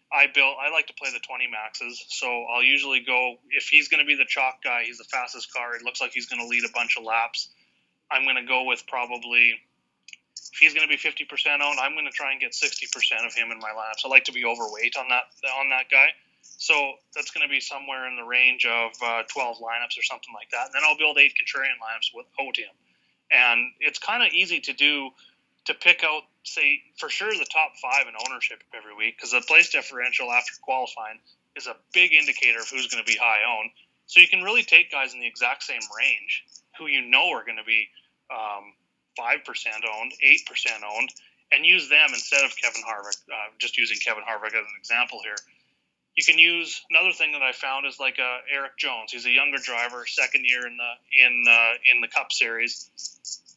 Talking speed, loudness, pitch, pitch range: 225 wpm, -21 LUFS, 125 Hz, 120-140 Hz